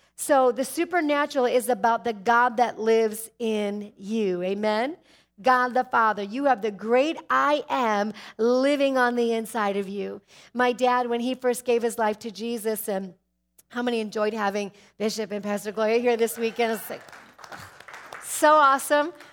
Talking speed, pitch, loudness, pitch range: 165 wpm, 230 Hz, -24 LUFS, 215-250 Hz